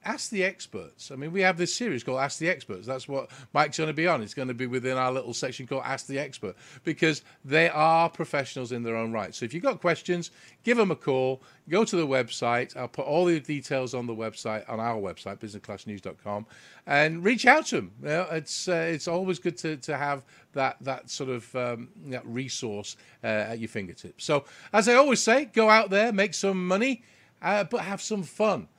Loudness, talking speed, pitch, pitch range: -27 LUFS, 225 wpm, 145 Hz, 125-180 Hz